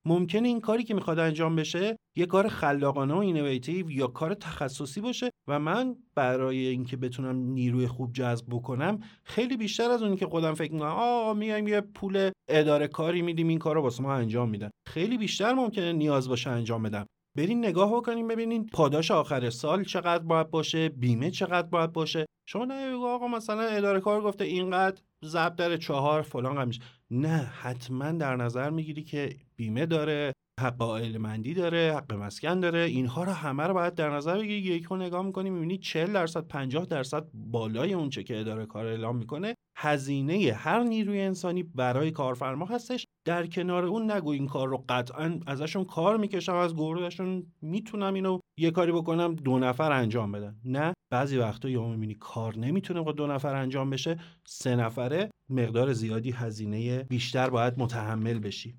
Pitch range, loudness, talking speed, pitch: 130-185 Hz, -29 LUFS, 175 wpm, 160 Hz